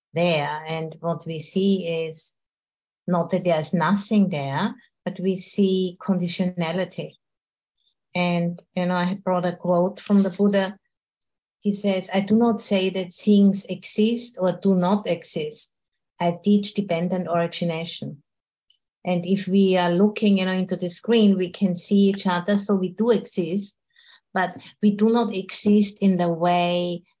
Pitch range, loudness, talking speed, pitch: 175-200 Hz, -23 LUFS, 150 wpm, 185 Hz